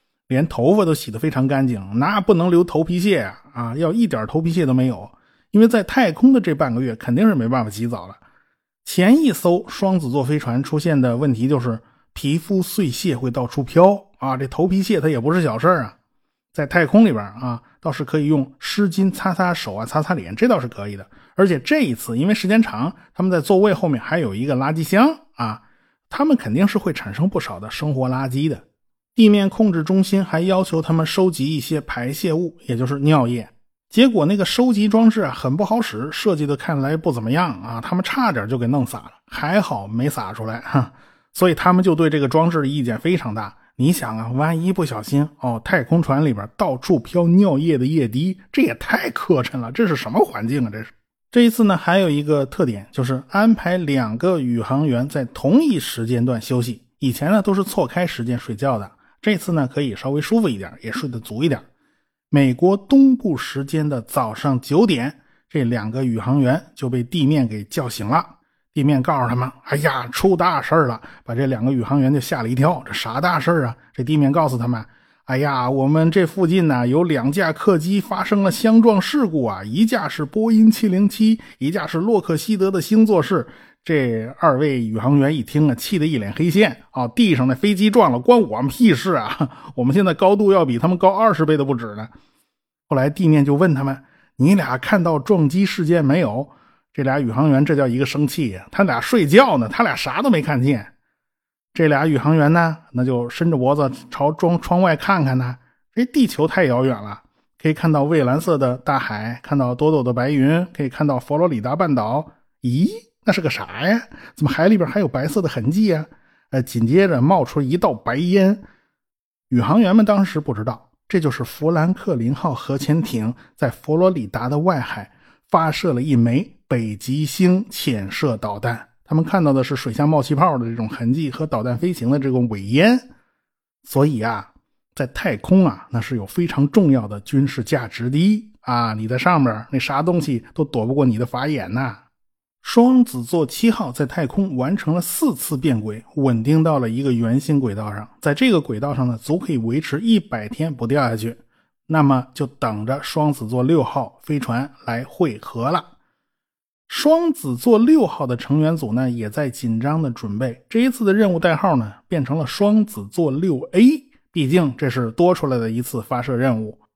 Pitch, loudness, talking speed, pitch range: 150 Hz, -19 LUFS, 290 characters per minute, 125-185 Hz